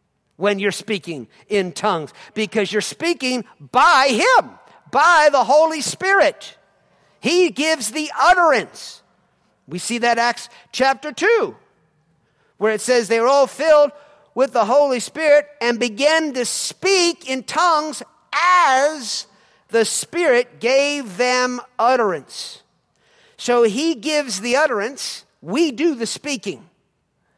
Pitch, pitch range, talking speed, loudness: 260 Hz, 230-310 Hz, 125 wpm, -18 LUFS